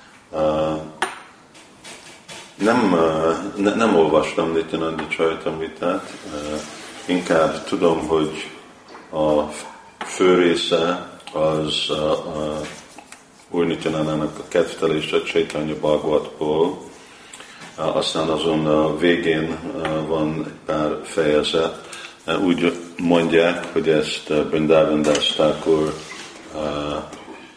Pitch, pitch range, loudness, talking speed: 80 Hz, 75-80 Hz, -20 LUFS, 105 wpm